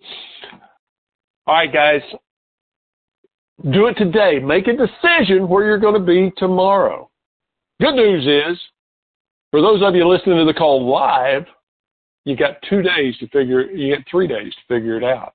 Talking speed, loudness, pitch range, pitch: 165 wpm, -15 LUFS, 145-205 Hz, 180 Hz